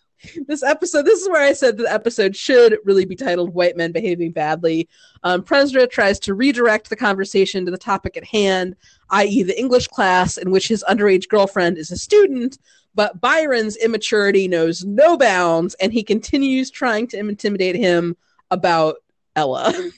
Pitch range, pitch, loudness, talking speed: 185-250 Hz, 205 Hz, -17 LUFS, 170 wpm